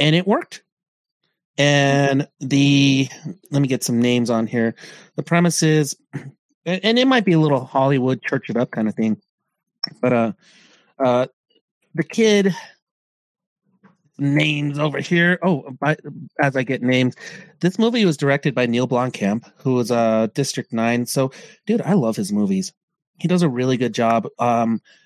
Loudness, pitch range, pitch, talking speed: -19 LUFS, 125-175 Hz, 145 Hz, 160 wpm